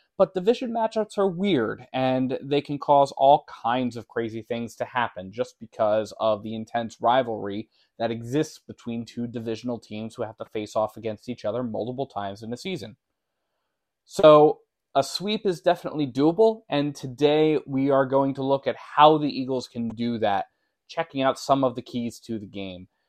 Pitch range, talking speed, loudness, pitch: 115-150 Hz, 180 wpm, -24 LUFS, 130 Hz